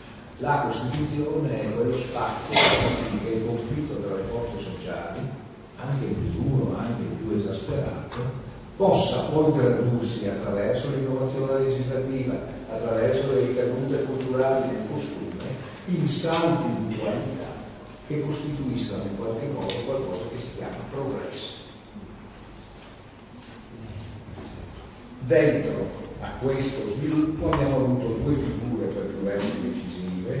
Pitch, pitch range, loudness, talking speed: 125 Hz, 110-135 Hz, -26 LUFS, 110 wpm